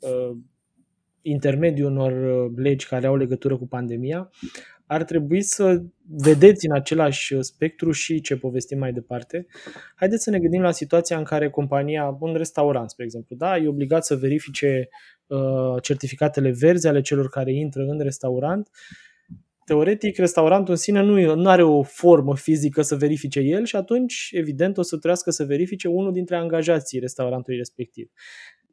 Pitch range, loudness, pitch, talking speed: 135-175 Hz, -21 LUFS, 150 Hz, 150 wpm